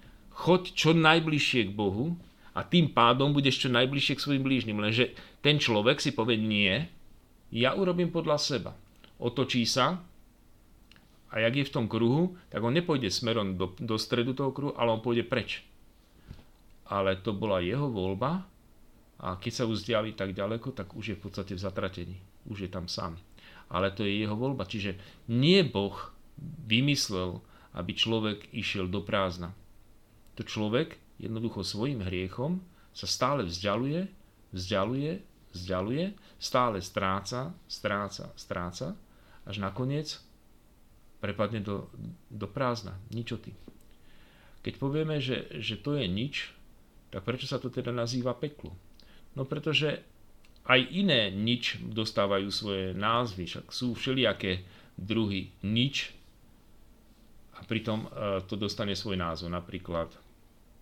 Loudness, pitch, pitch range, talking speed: -30 LUFS, 110 Hz, 100-130 Hz, 135 wpm